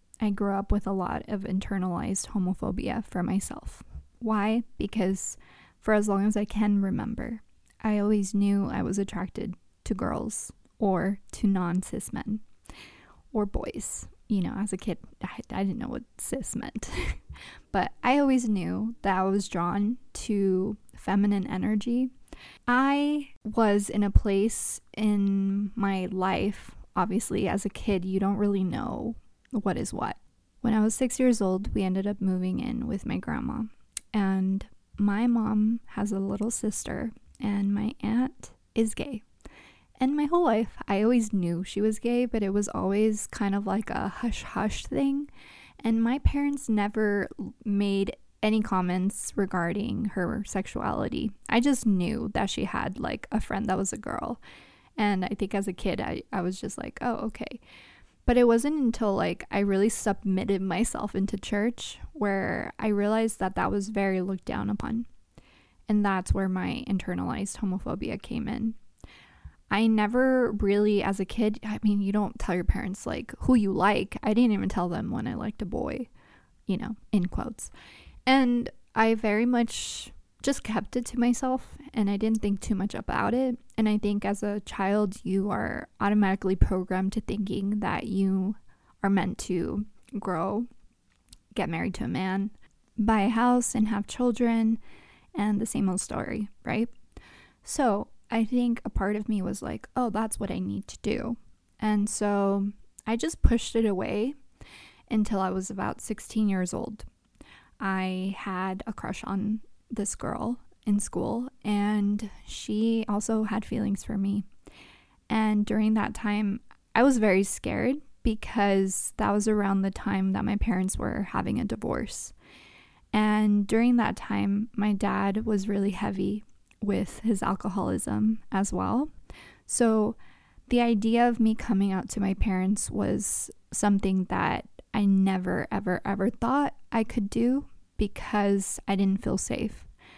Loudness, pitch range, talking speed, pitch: -28 LUFS, 195-225 Hz, 160 wpm, 210 Hz